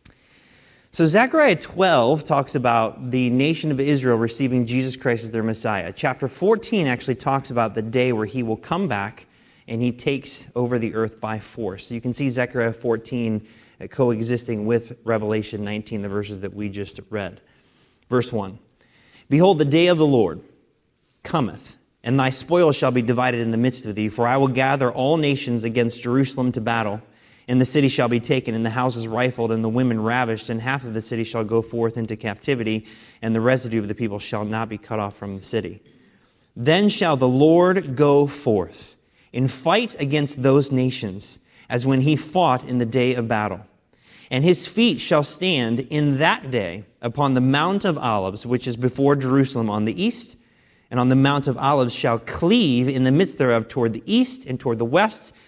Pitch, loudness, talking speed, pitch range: 125 Hz, -21 LUFS, 195 wpm, 115-135 Hz